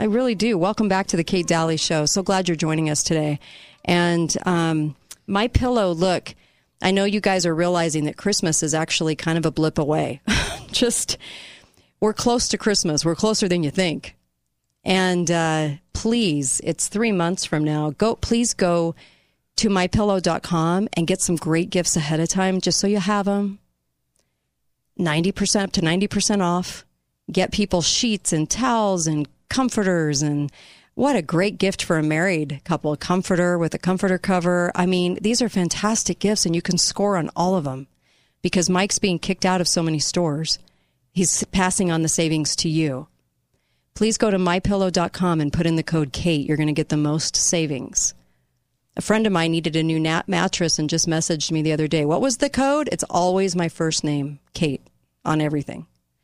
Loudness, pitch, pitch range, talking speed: -21 LUFS, 175 Hz, 155-195 Hz, 185 wpm